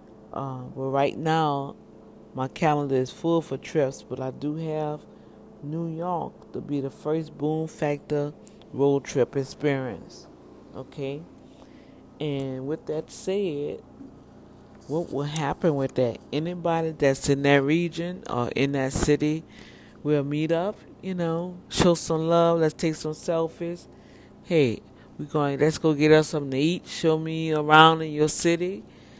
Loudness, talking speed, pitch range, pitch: -25 LUFS, 150 wpm, 140-165 Hz, 150 Hz